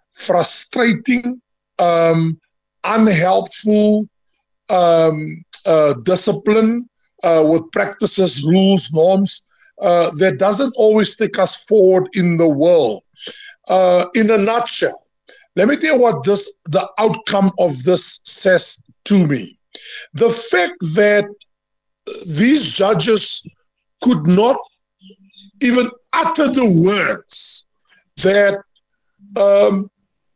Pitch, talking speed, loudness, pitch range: 200 Hz, 100 wpm, -15 LUFS, 180-230 Hz